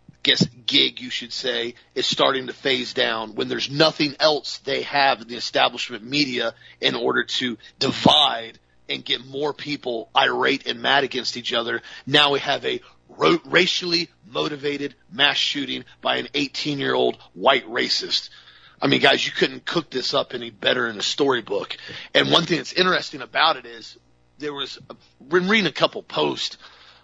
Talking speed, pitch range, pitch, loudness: 175 wpm, 120-155 Hz, 140 Hz, -21 LUFS